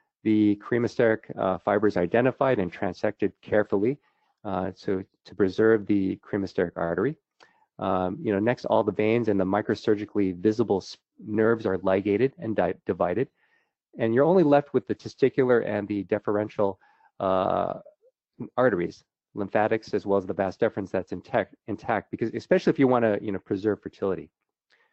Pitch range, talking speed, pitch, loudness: 100-110 Hz, 155 wpm, 105 Hz, -26 LUFS